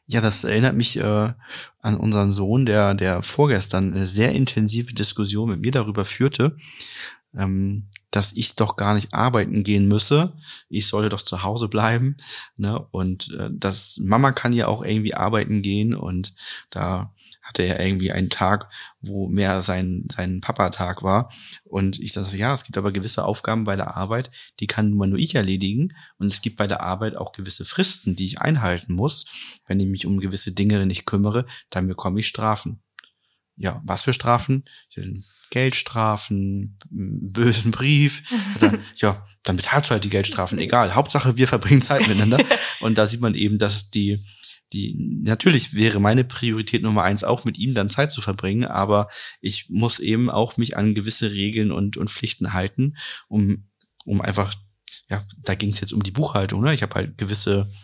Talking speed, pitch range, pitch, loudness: 175 wpm, 100-120 Hz, 105 Hz, -20 LUFS